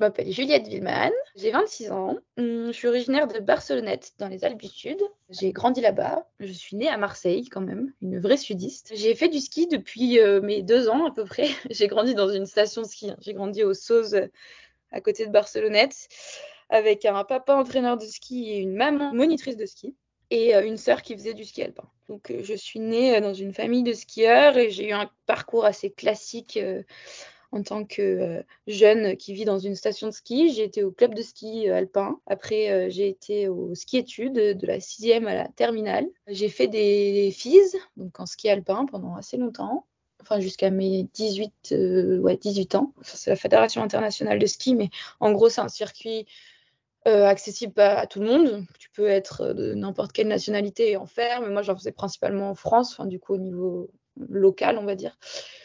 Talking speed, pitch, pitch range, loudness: 205 wpm, 215 Hz, 200-245 Hz, -24 LUFS